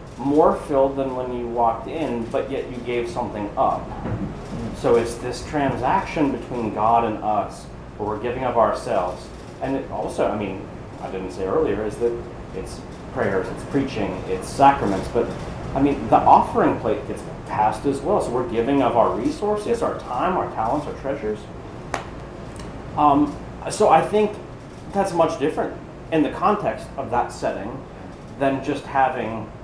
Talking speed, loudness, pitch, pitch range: 165 wpm, -22 LUFS, 135 Hz, 115-145 Hz